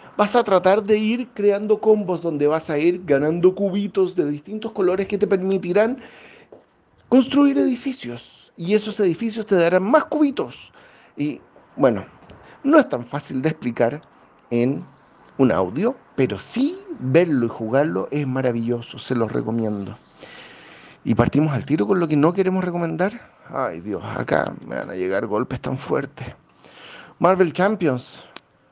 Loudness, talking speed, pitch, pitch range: -21 LUFS, 150 wpm, 180 Hz, 130-210 Hz